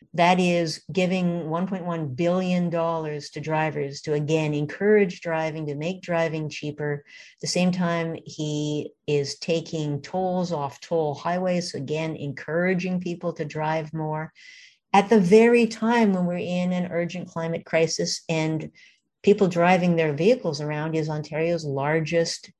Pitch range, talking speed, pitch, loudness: 155-180 Hz, 140 wpm, 165 Hz, -24 LUFS